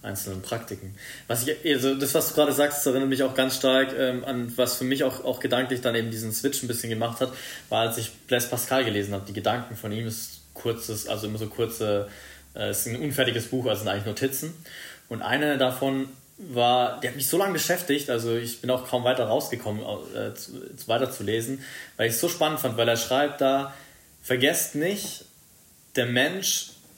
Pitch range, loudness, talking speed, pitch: 115-135 Hz, -26 LUFS, 205 wpm, 125 Hz